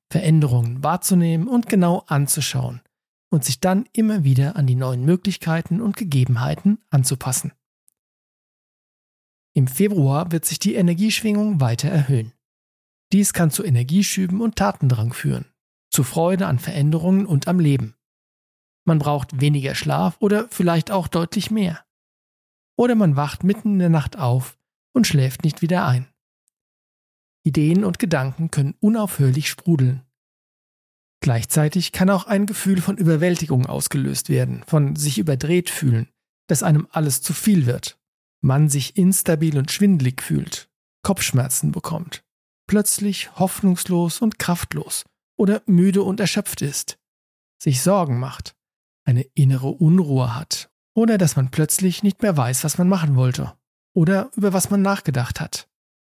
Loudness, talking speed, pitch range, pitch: -20 LUFS, 135 wpm, 135-190 Hz, 160 Hz